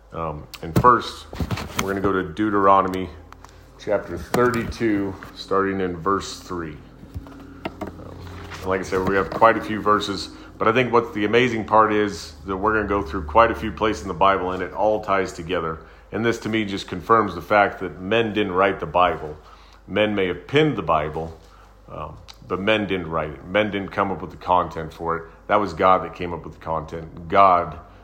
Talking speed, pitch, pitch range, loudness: 210 wpm, 95 Hz, 85-105 Hz, -21 LUFS